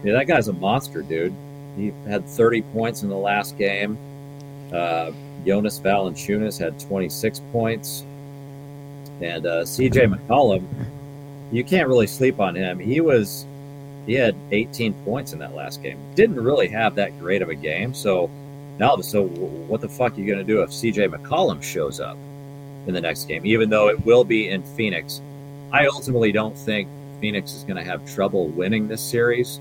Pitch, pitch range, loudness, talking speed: 125 Hz, 105-140 Hz, -22 LUFS, 180 wpm